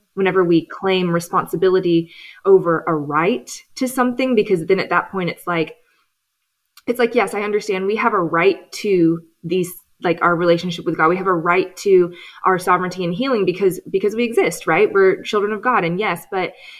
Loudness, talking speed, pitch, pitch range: -18 LUFS, 190 wpm, 185 Hz, 175-210 Hz